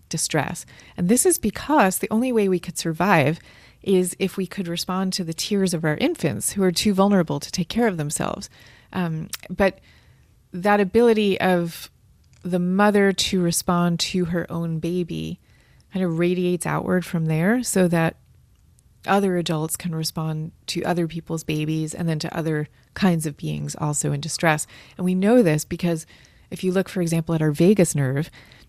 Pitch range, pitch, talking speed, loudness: 160-190 Hz, 175 Hz, 175 wpm, -22 LUFS